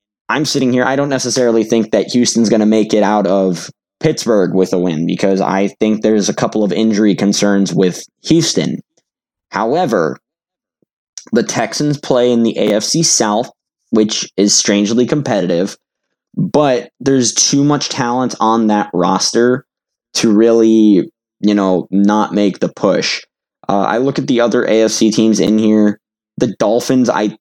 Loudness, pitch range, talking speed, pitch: -13 LUFS, 100-120 Hz, 155 wpm, 110 Hz